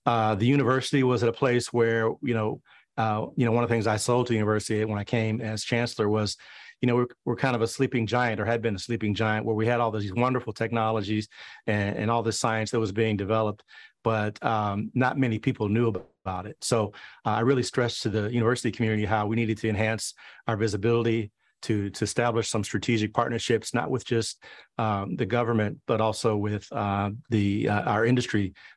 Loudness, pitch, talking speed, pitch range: -26 LUFS, 115 Hz, 215 wpm, 110-120 Hz